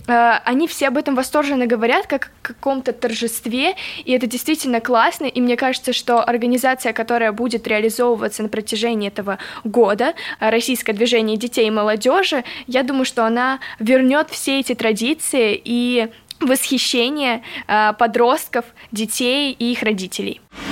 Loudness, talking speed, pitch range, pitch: -18 LUFS, 135 wpm, 230-260 Hz, 245 Hz